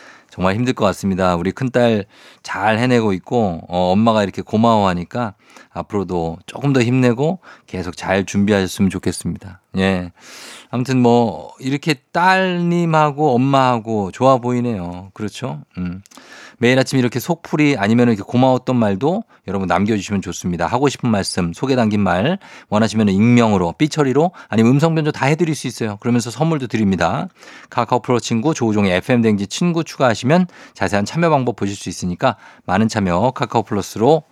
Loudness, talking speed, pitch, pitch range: -17 LUFS, 365 characters per minute, 115 Hz, 95-130 Hz